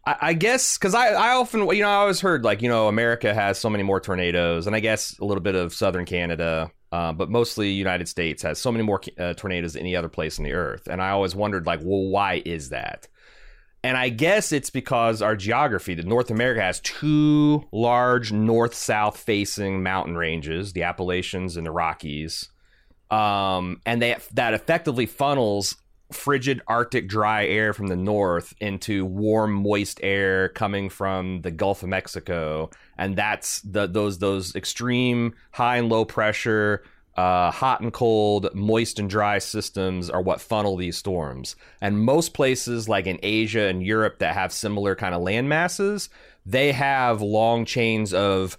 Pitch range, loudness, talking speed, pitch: 95-115 Hz, -23 LUFS, 180 wpm, 105 Hz